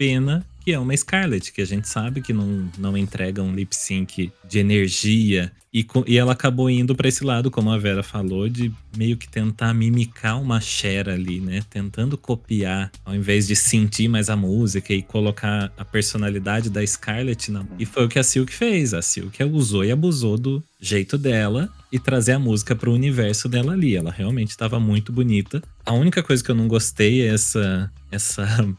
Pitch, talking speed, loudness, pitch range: 110 Hz, 200 wpm, -21 LUFS, 100-125 Hz